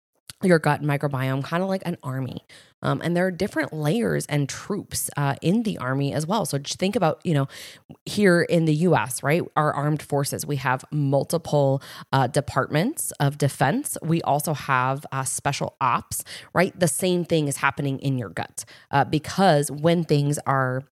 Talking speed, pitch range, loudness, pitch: 180 wpm, 135-170 Hz, -23 LUFS, 145 Hz